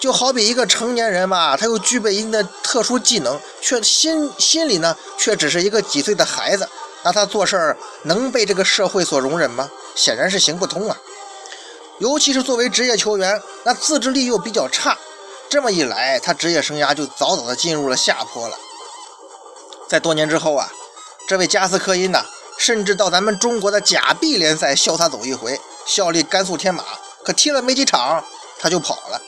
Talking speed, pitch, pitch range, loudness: 285 characters per minute, 210 Hz, 180-260 Hz, -17 LUFS